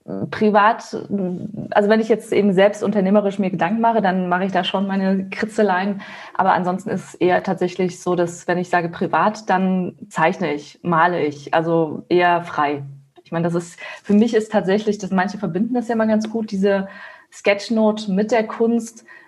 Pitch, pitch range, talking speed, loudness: 195 Hz, 175-215 Hz, 180 wpm, -19 LUFS